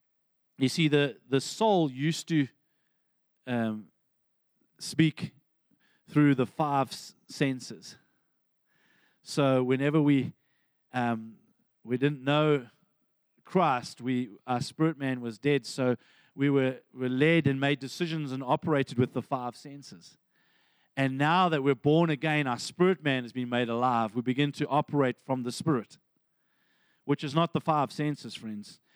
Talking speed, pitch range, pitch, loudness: 140 wpm, 125-150 Hz, 140 Hz, -28 LUFS